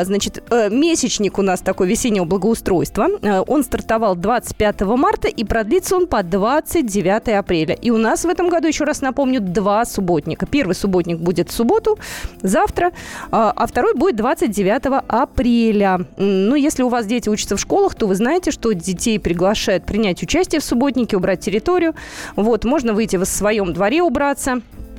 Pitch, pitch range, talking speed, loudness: 225 Hz, 200-285 Hz, 160 wpm, -17 LUFS